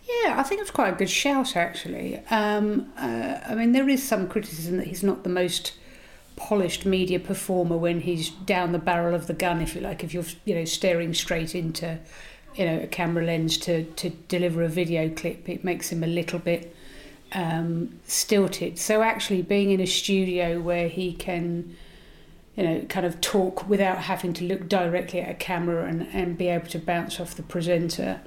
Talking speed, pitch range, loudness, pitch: 195 wpm, 170-190 Hz, -26 LUFS, 175 Hz